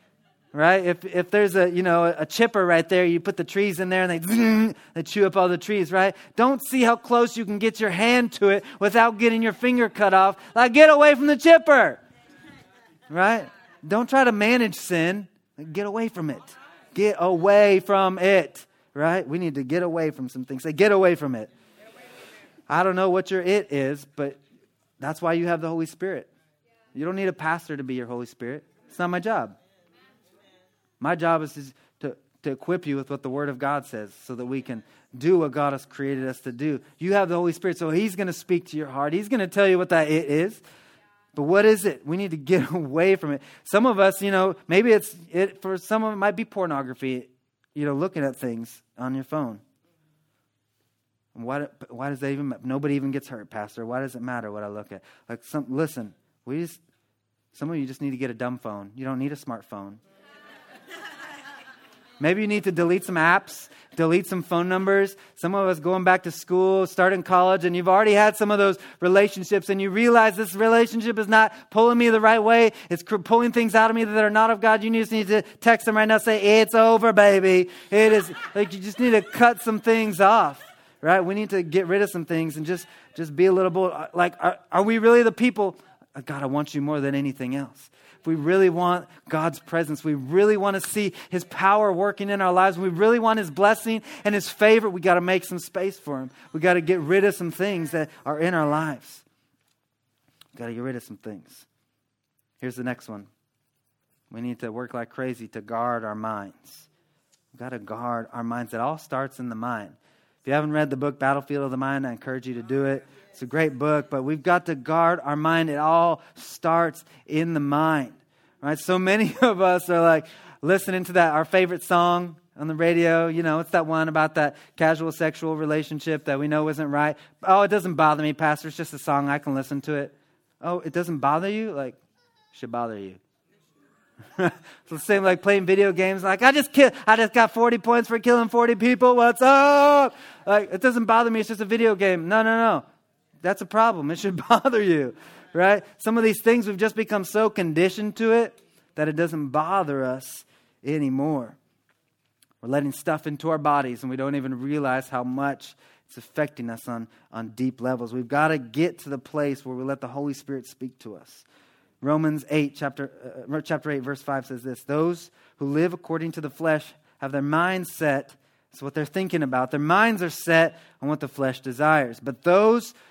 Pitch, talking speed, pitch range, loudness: 170 Hz, 220 wpm, 140-200 Hz, -22 LUFS